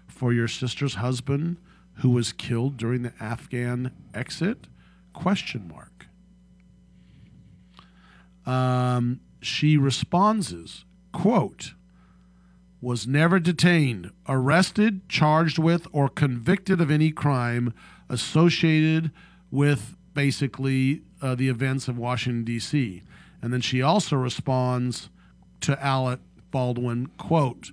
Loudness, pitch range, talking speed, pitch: -24 LUFS, 120-160 Hz, 100 wpm, 130 Hz